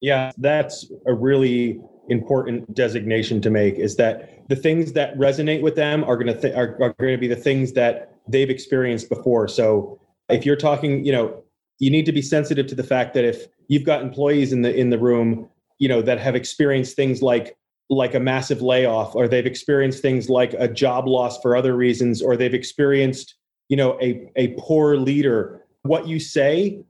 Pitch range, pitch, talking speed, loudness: 125-145 Hz, 130 Hz, 200 wpm, -20 LUFS